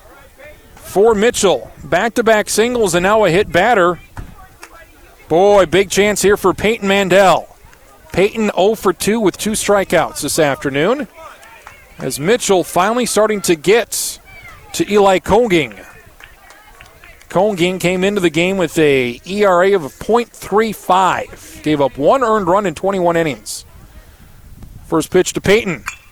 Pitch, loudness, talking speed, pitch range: 185 Hz, -14 LUFS, 130 wpm, 155-205 Hz